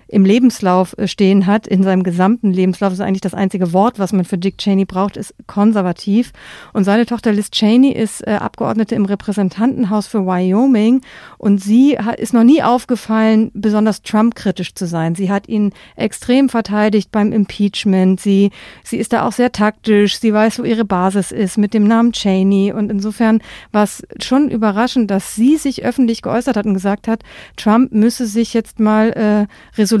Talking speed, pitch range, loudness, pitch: 180 wpm, 195-230 Hz, -15 LUFS, 210 Hz